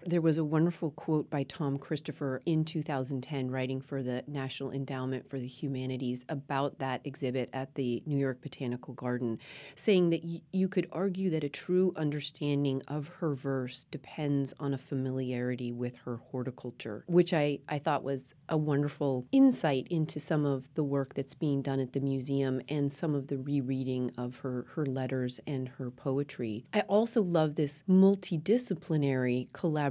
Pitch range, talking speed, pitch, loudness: 130-155 Hz, 170 wpm, 140 Hz, -32 LUFS